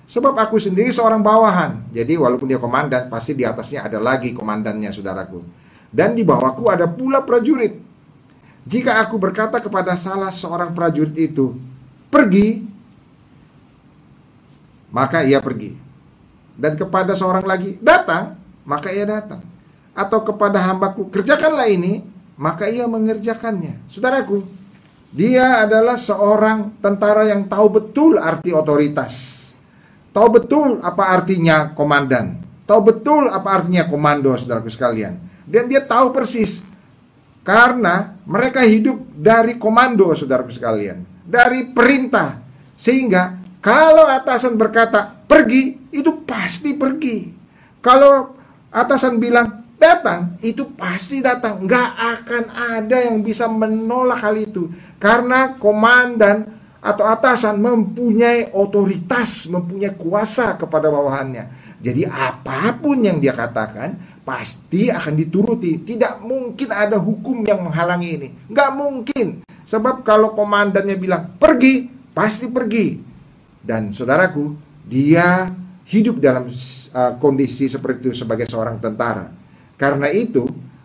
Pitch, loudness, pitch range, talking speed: 205 Hz, -16 LUFS, 160-235 Hz, 115 wpm